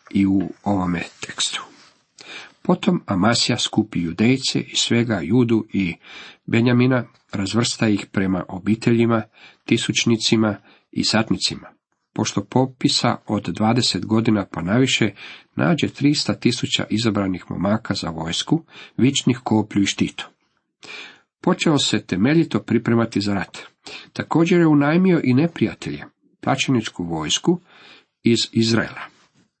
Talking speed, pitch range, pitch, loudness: 105 wpm, 100-125 Hz, 110 Hz, -20 LUFS